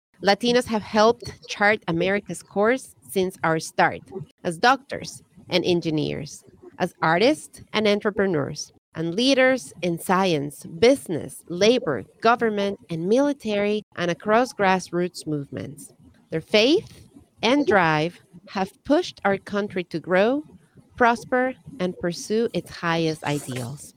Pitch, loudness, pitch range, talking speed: 190 Hz, -23 LUFS, 165-220 Hz, 115 wpm